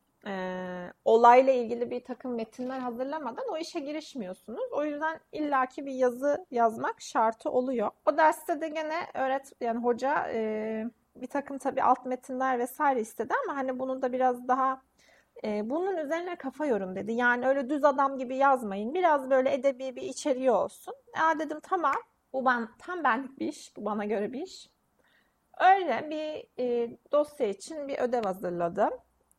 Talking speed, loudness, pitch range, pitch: 160 wpm, -29 LUFS, 240-305 Hz, 265 Hz